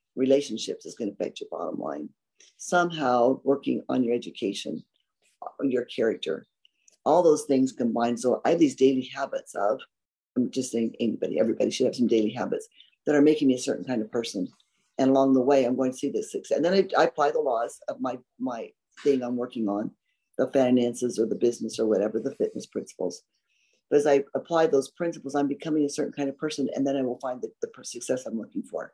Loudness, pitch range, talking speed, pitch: -26 LUFS, 125-145 Hz, 215 wpm, 135 Hz